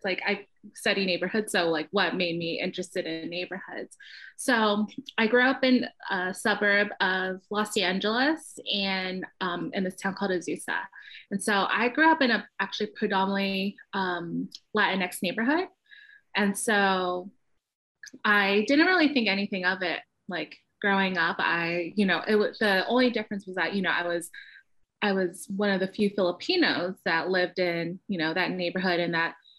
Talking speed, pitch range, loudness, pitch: 170 wpm, 180-215 Hz, -26 LUFS, 195 Hz